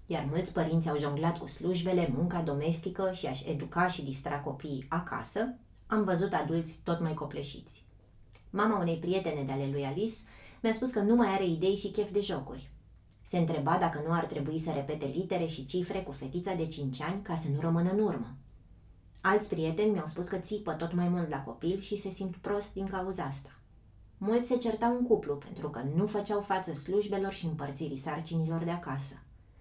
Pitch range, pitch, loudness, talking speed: 145-195 Hz, 165 Hz, -33 LUFS, 195 wpm